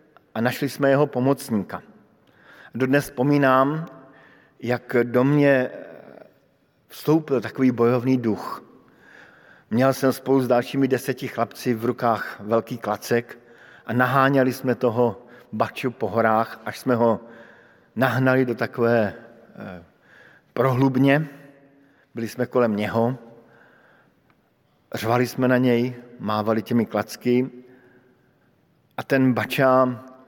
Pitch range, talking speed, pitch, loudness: 115-130 Hz, 105 wpm, 125 Hz, -22 LUFS